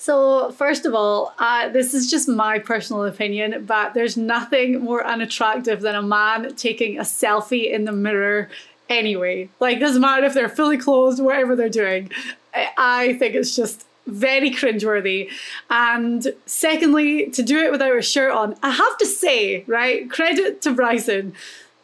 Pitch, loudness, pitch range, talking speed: 240 Hz, -19 LUFS, 215-270 Hz, 160 wpm